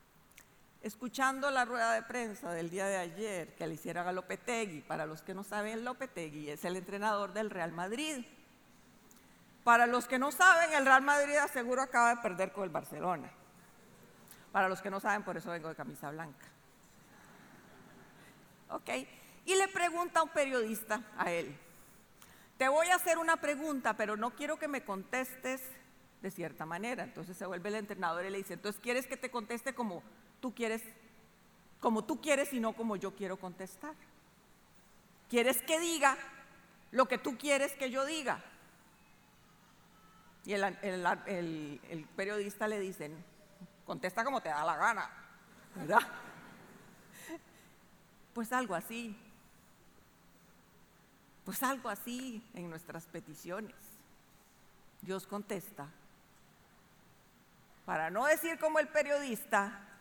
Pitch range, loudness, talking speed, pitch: 185-260 Hz, -34 LUFS, 145 wpm, 215 Hz